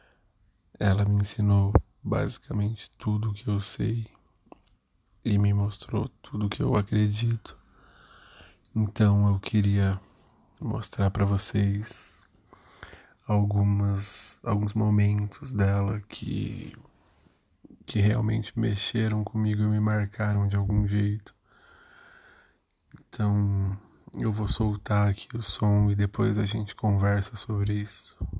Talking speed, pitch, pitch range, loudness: 110 wpm, 105 Hz, 100-110 Hz, -27 LUFS